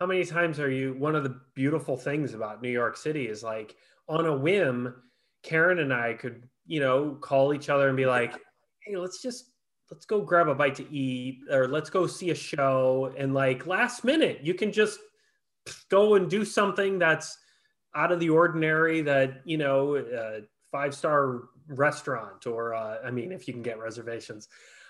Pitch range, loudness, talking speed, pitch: 130-170 Hz, -27 LUFS, 190 wpm, 140 Hz